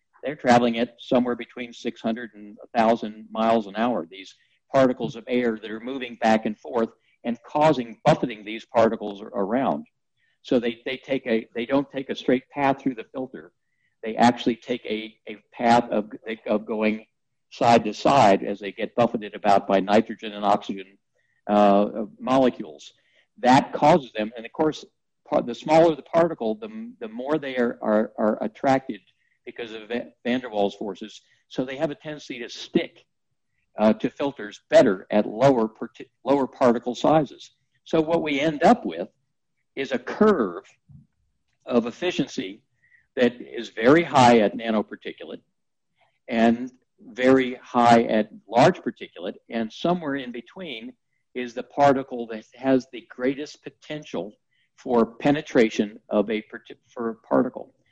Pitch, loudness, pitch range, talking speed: 120 Hz, -23 LUFS, 110-135 Hz, 155 wpm